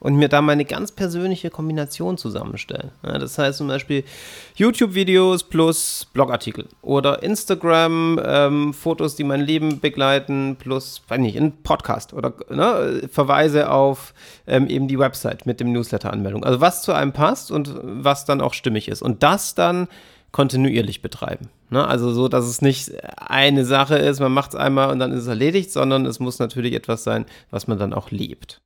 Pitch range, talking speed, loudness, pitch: 125-155 Hz, 175 wpm, -20 LUFS, 140 Hz